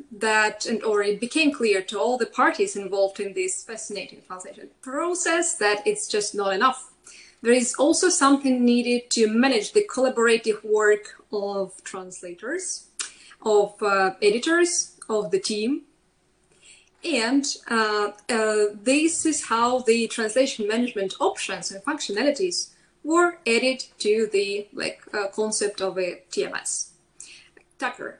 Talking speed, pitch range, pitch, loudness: 130 wpm, 205-290 Hz, 230 Hz, -23 LUFS